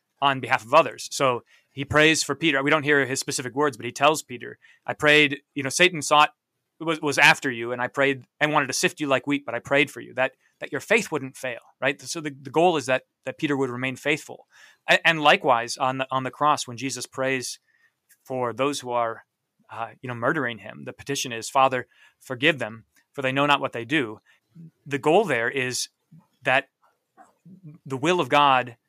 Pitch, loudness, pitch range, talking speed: 140 Hz, -23 LUFS, 125-150 Hz, 215 wpm